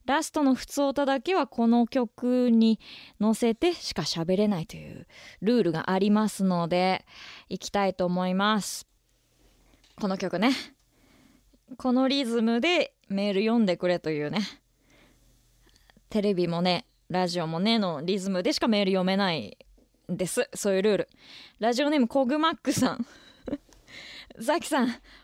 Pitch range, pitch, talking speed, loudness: 185-265 Hz, 225 Hz, 285 characters per minute, -26 LUFS